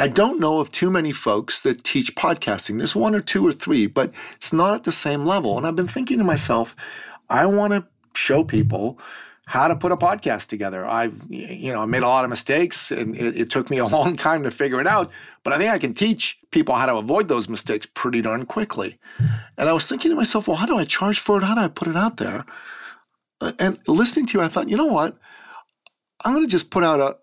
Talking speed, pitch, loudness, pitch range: 245 wpm, 170 Hz, -21 LUFS, 130-210 Hz